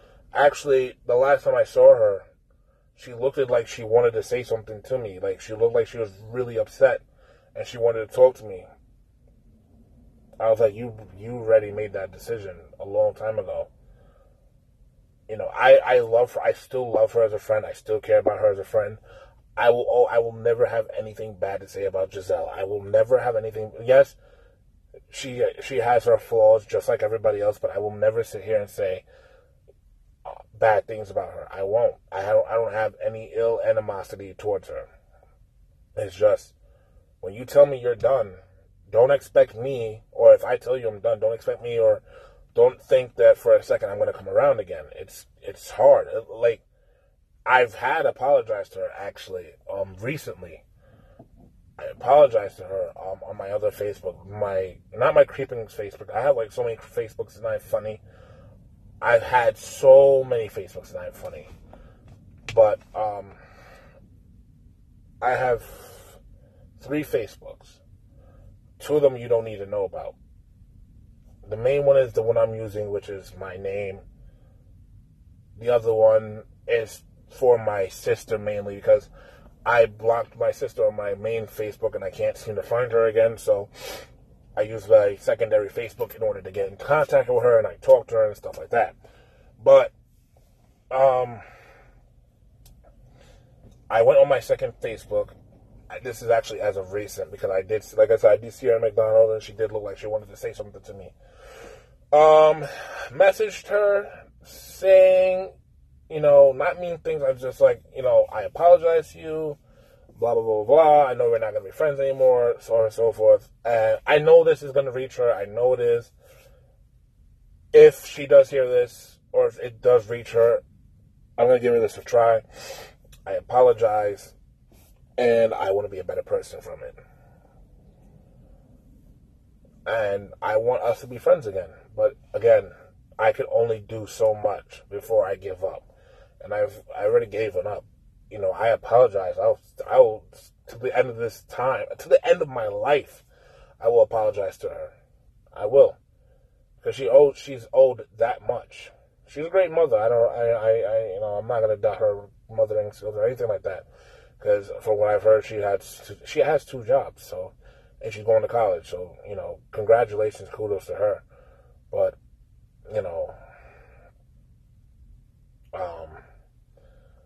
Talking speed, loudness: 180 wpm, -22 LUFS